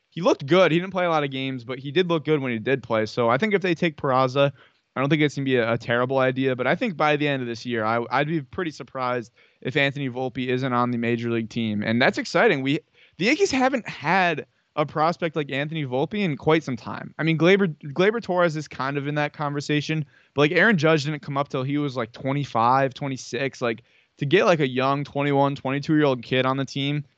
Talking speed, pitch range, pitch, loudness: 250 wpm, 130-160 Hz, 140 Hz, -23 LUFS